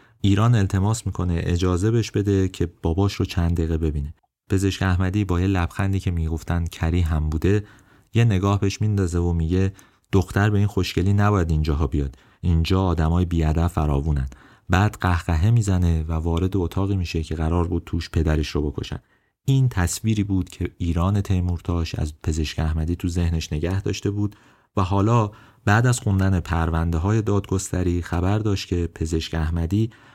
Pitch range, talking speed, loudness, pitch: 85-100 Hz, 160 wpm, -23 LUFS, 90 Hz